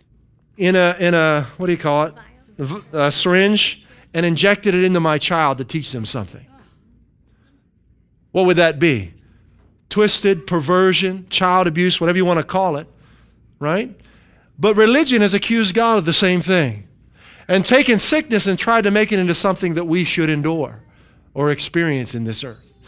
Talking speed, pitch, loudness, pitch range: 170 wpm, 175 Hz, -16 LUFS, 145-195 Hz